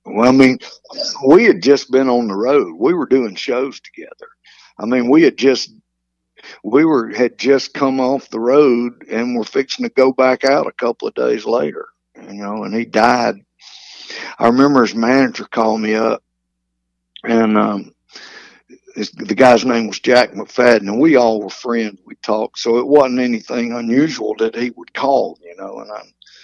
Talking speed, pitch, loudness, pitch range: 185 wpm, 125 Hz, -15 LUFS, 110-140 Hz